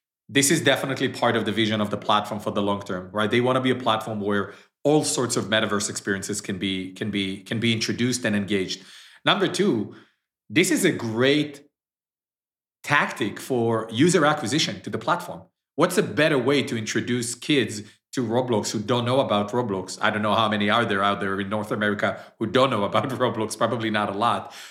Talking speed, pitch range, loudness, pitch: 205 wpm, 105-125 Hz, -23 LUFS, 110 Hz